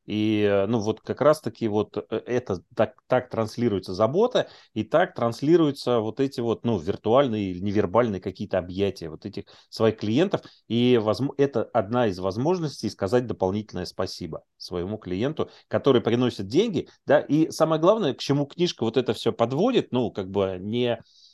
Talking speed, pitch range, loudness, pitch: 155 wpm, 100-125 Hz, -25 LUFS, 110 Hz